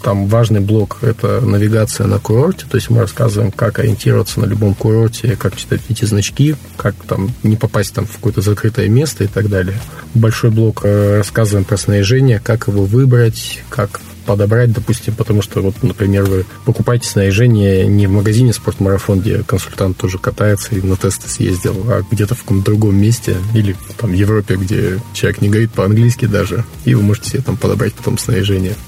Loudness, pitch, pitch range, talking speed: -14 LUFS, 110 Hz, 100-115 Hz, 180 wpm